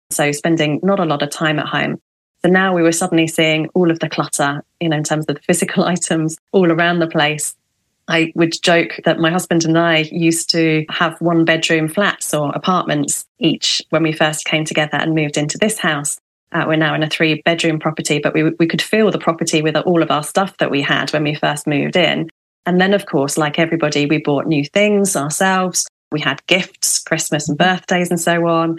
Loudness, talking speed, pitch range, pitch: -16 LUFS, 220 wpm, 155-175 Hz, 160 Hz